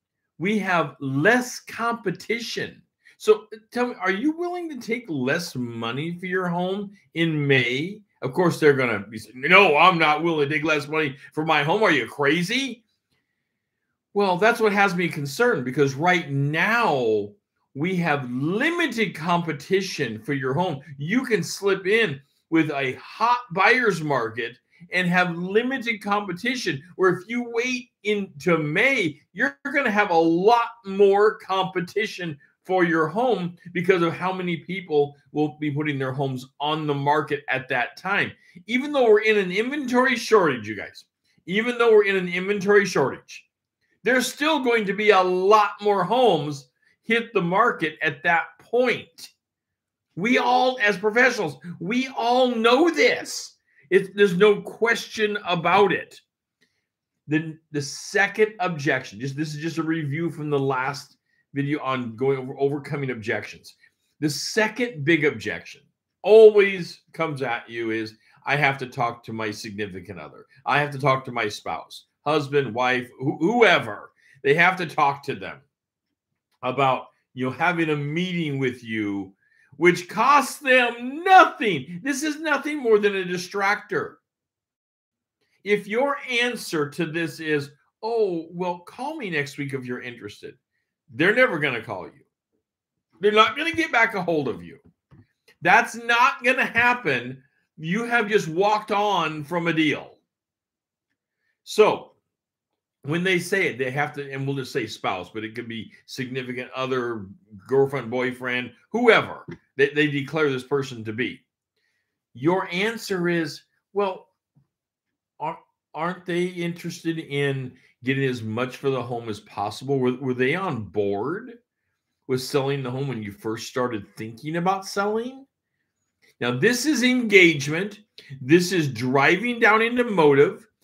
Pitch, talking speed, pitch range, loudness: 175 Hz, 155 wpm, 140-215 Hz, -22 LUFS